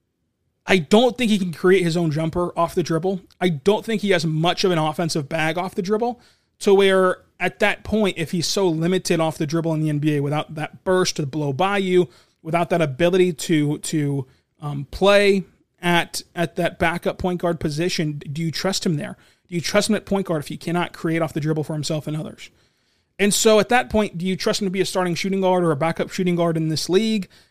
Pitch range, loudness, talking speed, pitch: 160-190 Hz, -21 LUFS, 235 wpm, 175 Hz